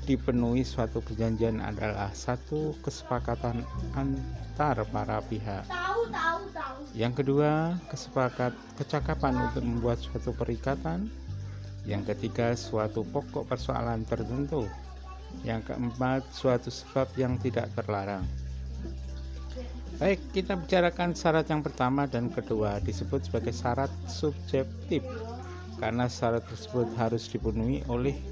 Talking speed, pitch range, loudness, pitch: 100 wpm, 100-135 Hz, -31 LUFS, 120 Hz